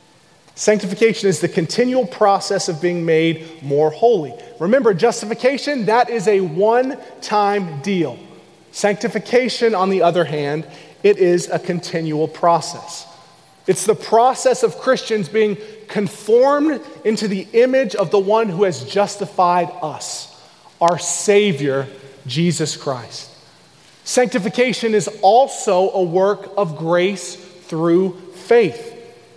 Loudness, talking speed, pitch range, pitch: -17 LUFS, 115 wpm, 170-225 Hz, 195 Hz